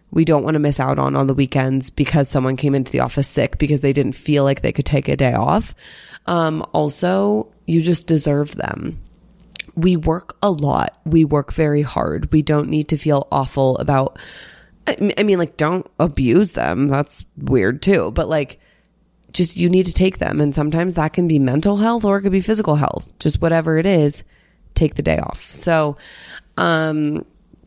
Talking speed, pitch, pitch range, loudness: 195 wpm, 150 Hz, 140-175 Hz, -18 LUFS